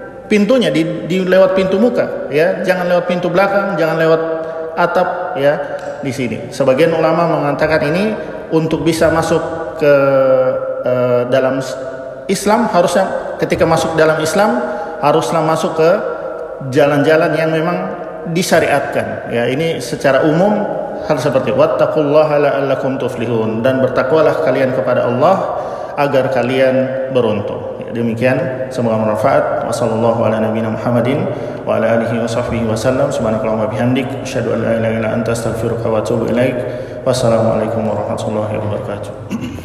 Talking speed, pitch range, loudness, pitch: 125 wpm, 120-165 Hz, -15 LUFS, 140 Hz